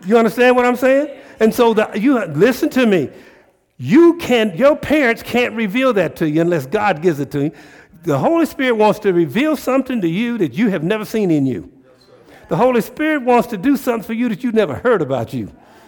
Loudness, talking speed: -16 LUFS, 220 wpm